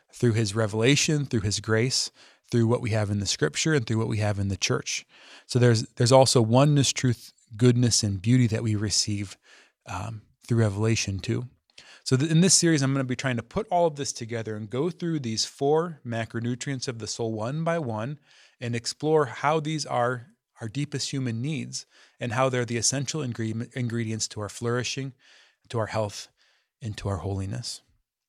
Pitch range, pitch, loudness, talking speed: 110-135 Hz, 120 Hz, -25 LUFS, 195 wpm